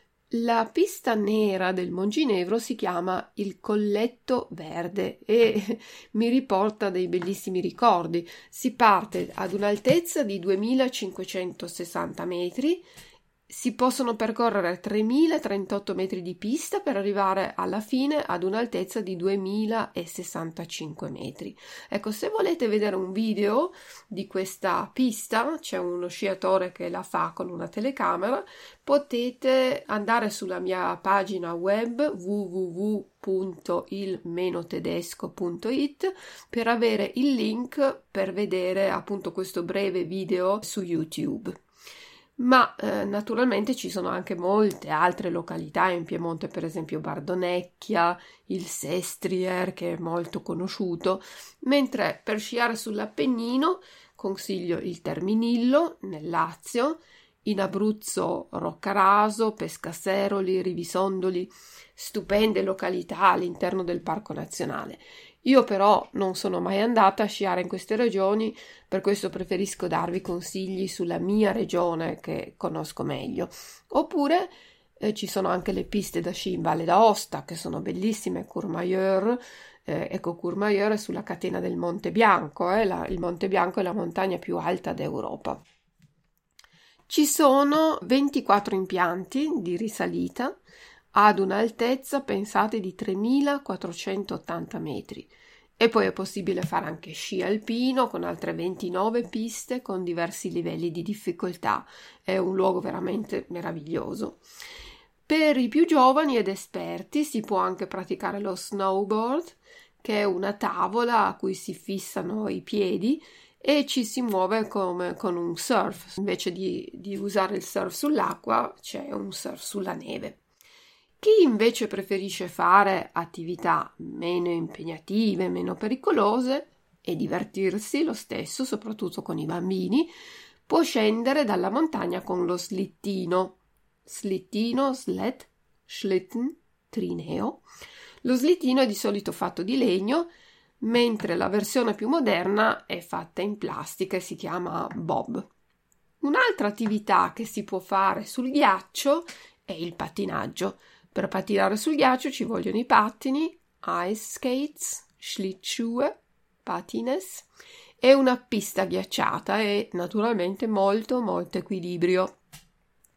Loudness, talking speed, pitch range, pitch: -26 LUFS, 120 wpm, 185-240 Hz, 200 Hz